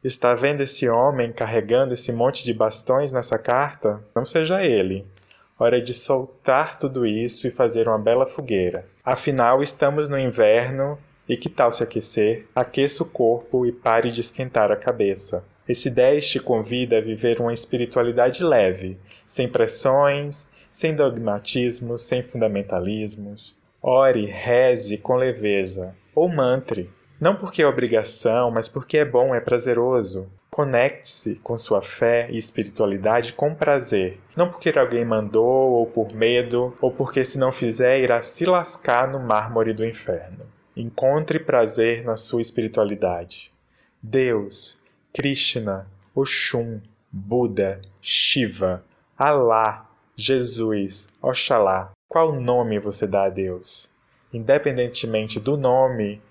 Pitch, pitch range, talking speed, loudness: 120 Hz, 110-130 Hz, 130 wpm, -21 LUFS